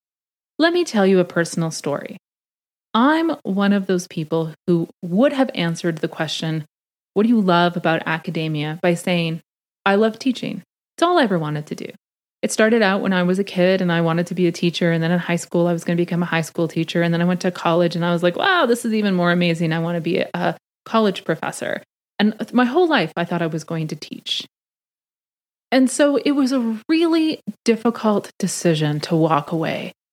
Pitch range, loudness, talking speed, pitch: 170-220 Hz, -20 LUFS, 220 wpm, 180 Hz